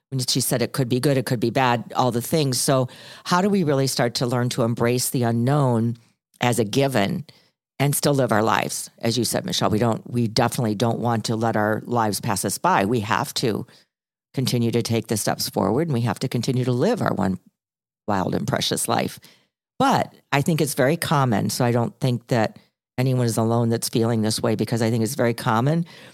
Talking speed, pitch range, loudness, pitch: 225 wpm, 115-135 Hz, -22 LUFS, 120 Hz